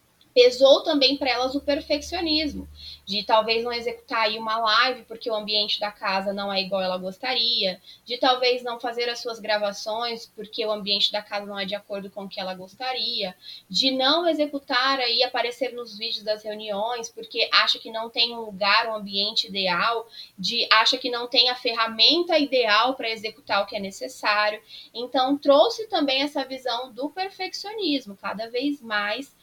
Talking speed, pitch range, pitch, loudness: 180 wpm, 210-260 Hz, 230 Hz, -23 LUFS